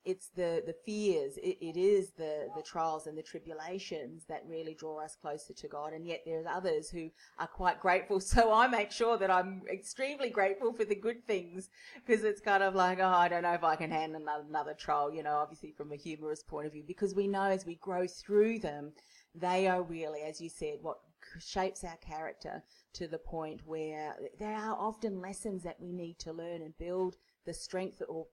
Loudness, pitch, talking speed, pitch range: -35 LUFS, 180 Hz, 215 wpm, 160-200 Hz